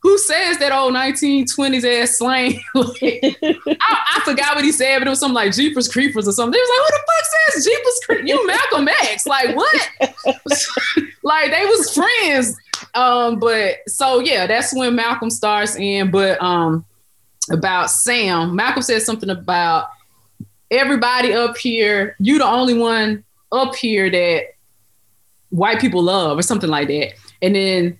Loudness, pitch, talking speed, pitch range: -16 LUFS, 250 Hz, 165 wpm, 210-290 Hz